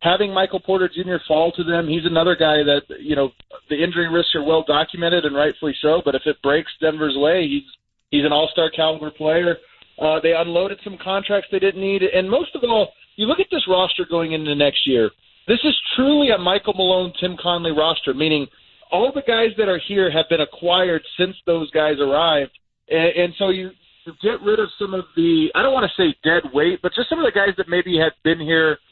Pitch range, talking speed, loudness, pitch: 160-195 Hz, 220 wpm, -19 LUFS, 175 Hz